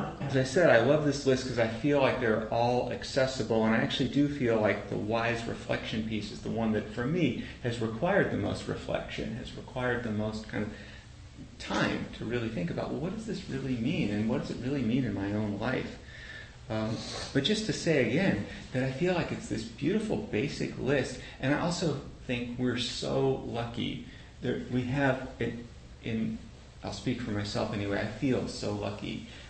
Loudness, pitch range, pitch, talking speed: -31 LUFS, 110-130 Hz, 120 Hz, 205 wpm